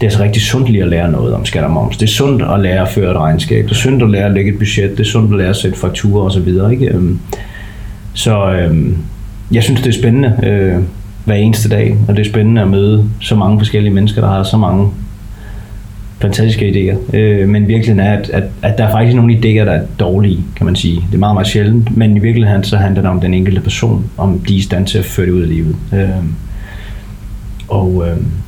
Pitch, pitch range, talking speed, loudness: 100 Hz, 95-110 Hz, 250 wpm, -12 LUFS